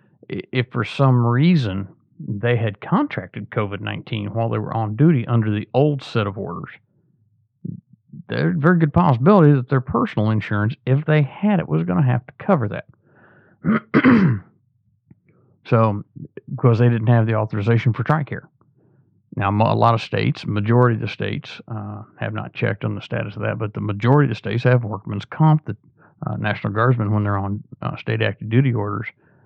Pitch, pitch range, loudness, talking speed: 120 Hz, 105-145 Hz, -20 LUFS, 180 wpm